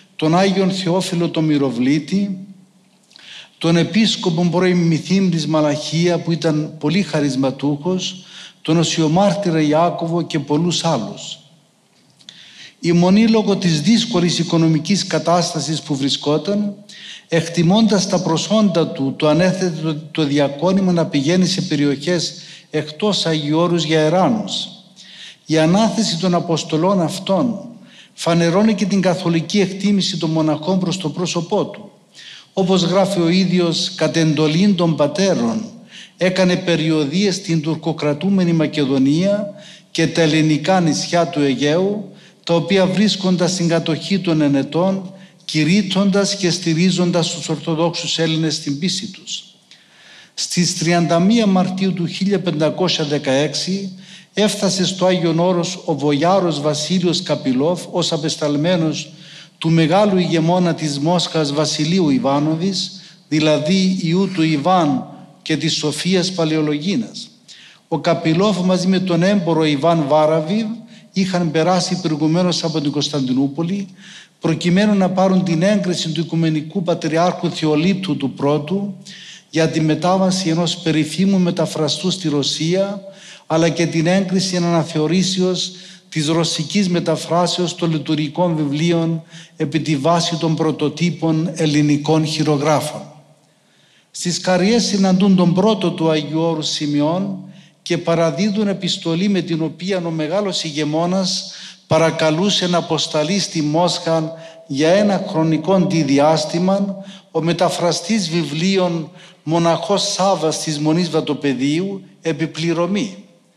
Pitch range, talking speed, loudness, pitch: 160-190 Hz, 115 wpm, -17 LUFS, 170 Hz